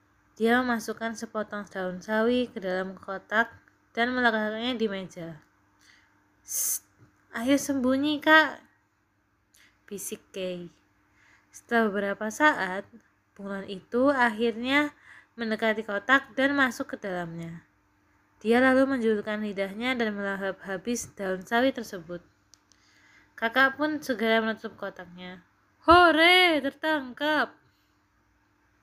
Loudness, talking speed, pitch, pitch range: -26 LUFS, 95 wpm, 215 Hz, 175-250 Hz